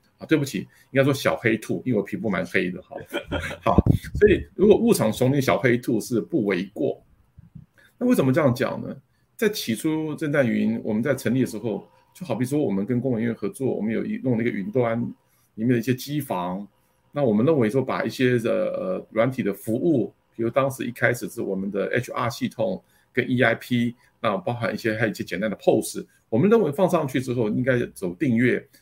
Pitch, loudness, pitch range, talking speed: 125 Hz, -24 LUFS, 110-145 Hz, 310 characters per minute